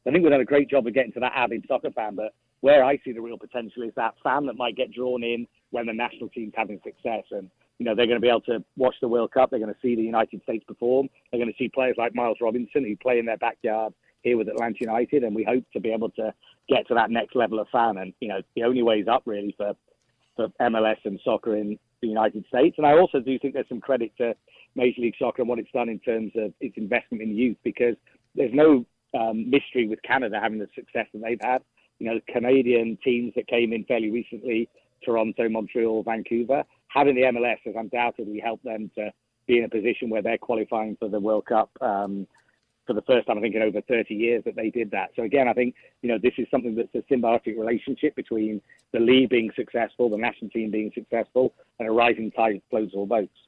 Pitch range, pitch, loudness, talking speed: 110-125 Hz, 115 Hz, -25 LUFS, 245 wpm